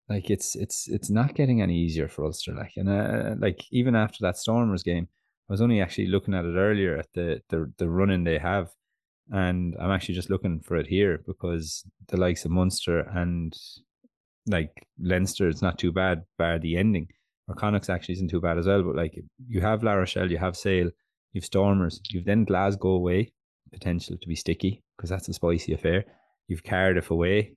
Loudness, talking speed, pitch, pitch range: -27 LUFS, 200 wpm, 95 Hz, 85-100 Hz